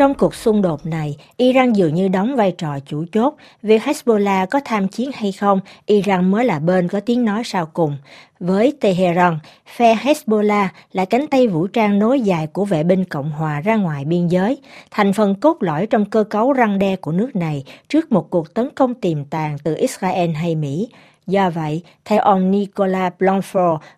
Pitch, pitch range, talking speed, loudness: 195 Hz, 175-225 Hz, 195 wpm, -18 LUFS